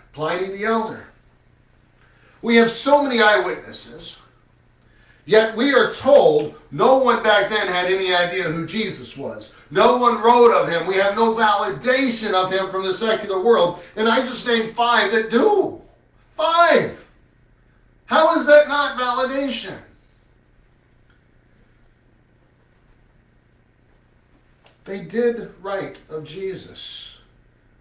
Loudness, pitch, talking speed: -18 LUFS, 190 Hz, 120 wpm